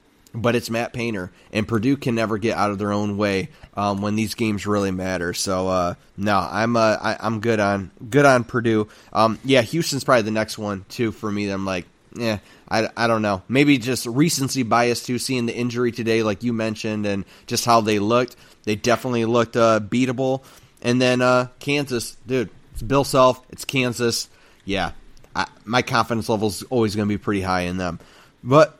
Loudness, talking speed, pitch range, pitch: -21 LUFS, 200 wpm, 105-125 Hz, 115 Hz